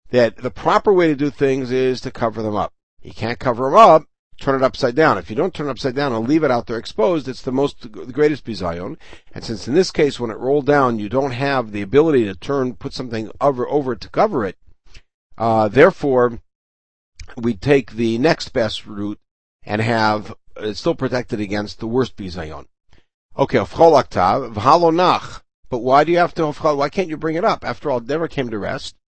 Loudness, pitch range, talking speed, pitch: -18 LUFS, 110-145 Hz, 210 wpm, 125 Hz